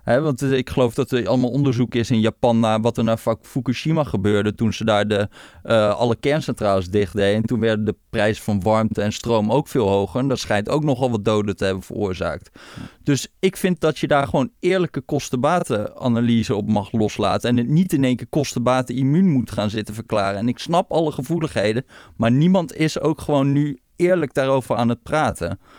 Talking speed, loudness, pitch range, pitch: 205 wpm, -20 LUFS, 105-145 Hz, 120 Hz